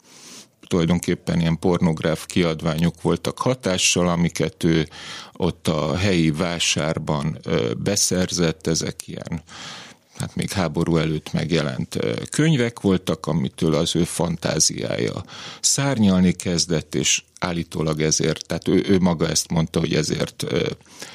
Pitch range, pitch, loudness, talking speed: 80-90 Hz, 85 Hz, -21 LUFS, 110 wpm